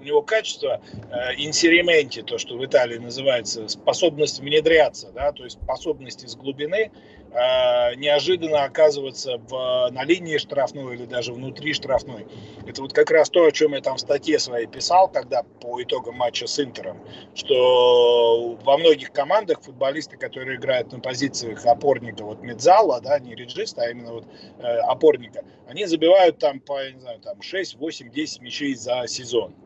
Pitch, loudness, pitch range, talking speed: 145 Hz, -21 LUFS, 125-185 Hz, 165 wpm